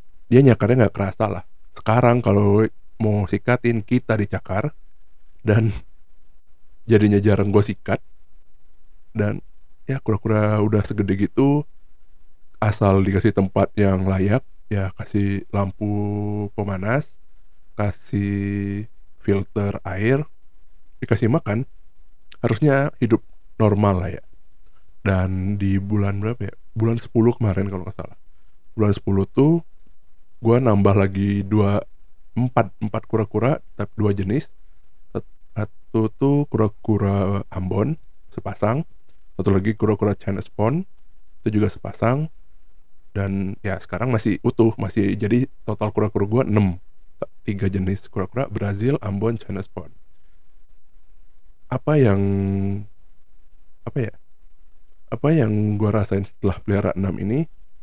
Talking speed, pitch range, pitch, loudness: 110 wpm, 95-110 Hz, 100 Hz, -21 LUFS